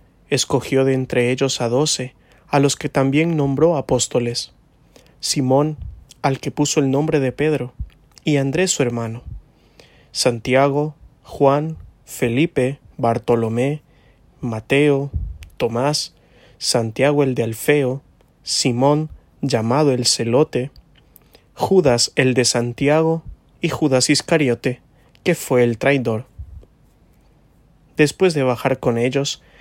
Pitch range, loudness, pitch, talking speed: 125-150 Hz, -19 LUFS, 135 Hz, 110 wpm